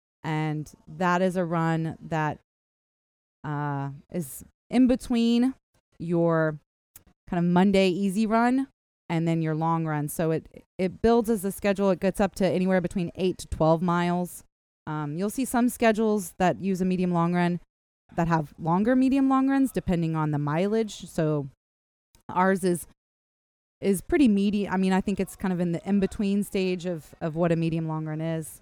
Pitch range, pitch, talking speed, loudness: 160-200 Hz, 180 Hz, 180 wpm, -26 LUFS